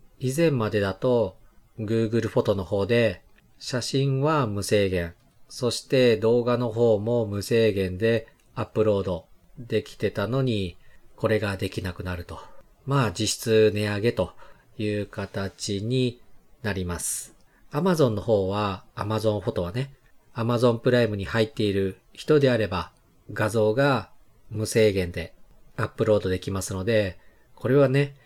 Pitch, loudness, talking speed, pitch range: 110 Hz, -25 LUFS, 295 characters per minute, 100-120 Hz